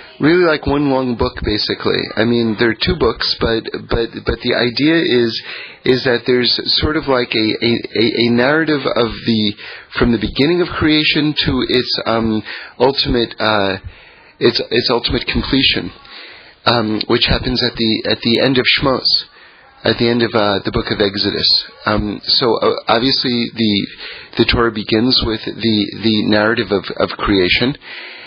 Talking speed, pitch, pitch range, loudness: 165 wpm, 115 Hz, 110-125 Hz, -15 LUFS